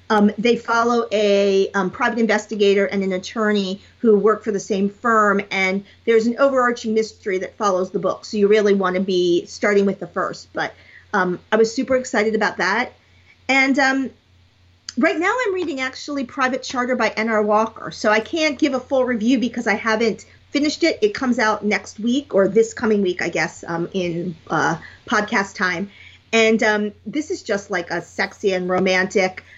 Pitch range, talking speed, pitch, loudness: 195-245 Hz, 190 wpm, 215 Hz, -19 LUFS